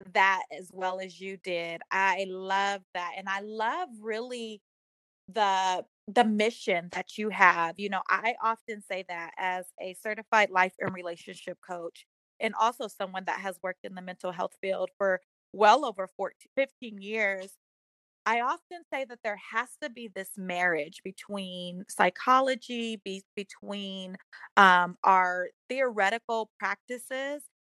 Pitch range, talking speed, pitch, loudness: 185-225 Hz, 145 wpm, 195 Hz, -29 LUFS